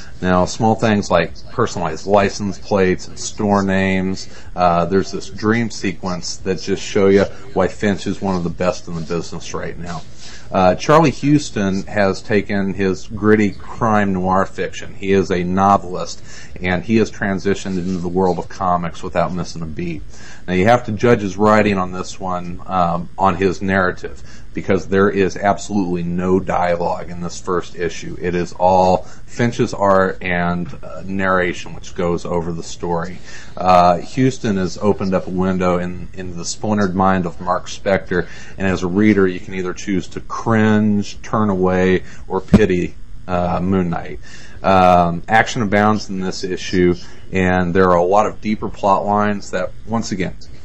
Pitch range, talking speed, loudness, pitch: 90-100 Hz, 175 wpm, -18 LUFS, 95 Hz